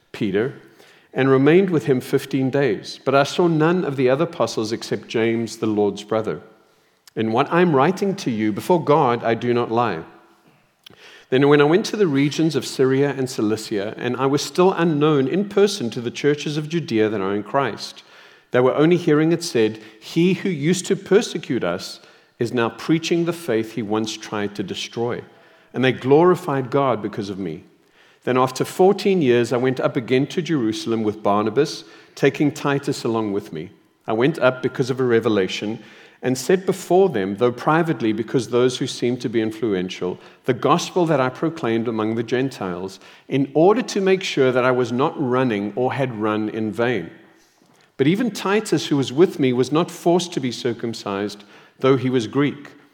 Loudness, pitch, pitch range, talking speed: -20 LUFS, 130 Hz, 115-160 Hz, 190 wpm